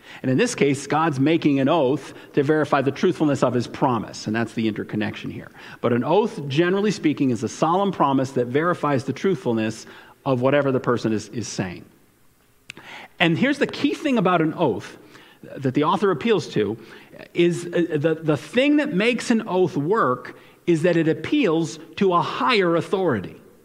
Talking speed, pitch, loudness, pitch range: 180 wpm, 155 Hz, -22 LUFS, 135-180 Hz